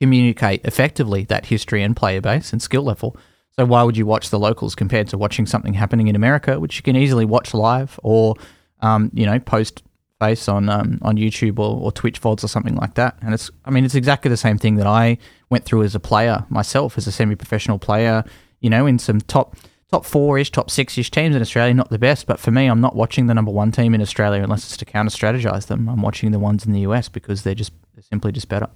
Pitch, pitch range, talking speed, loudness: 110 Hz, 105-125 Hz, 245 wpm, -18 LUFS